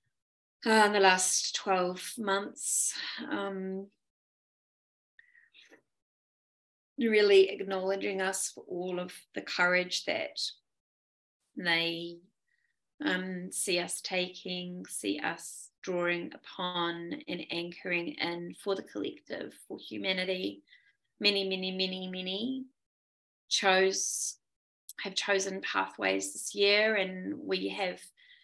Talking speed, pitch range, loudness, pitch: 95 wpm, 175-195 Hz, -31 LUFS, 185 Hz